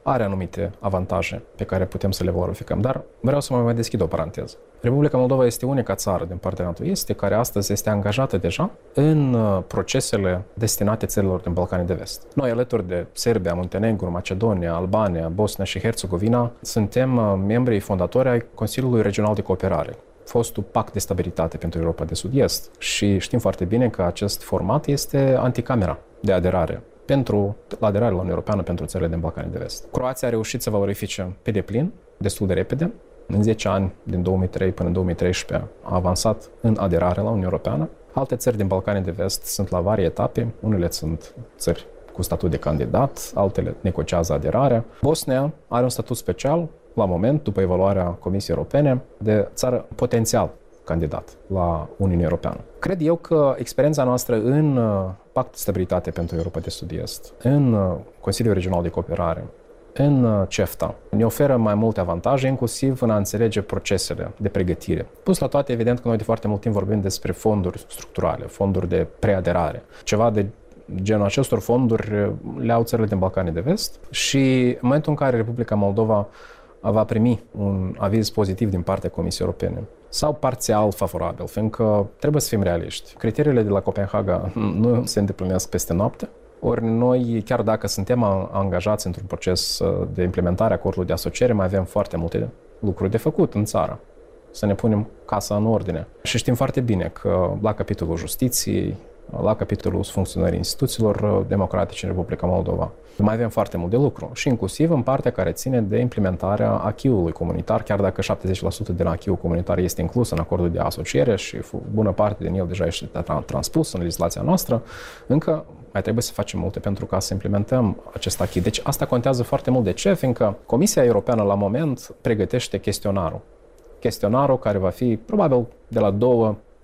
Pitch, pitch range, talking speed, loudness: 105 Hz, 95-120 Hz, 170 wpm, -22 LUFS